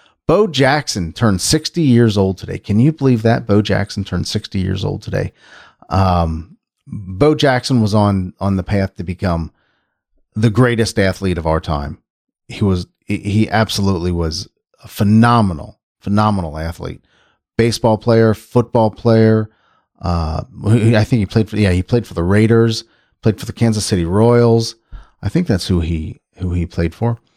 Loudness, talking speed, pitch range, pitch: -16 LUFS, 160 wpm, 95-115 Hz, 105 Hz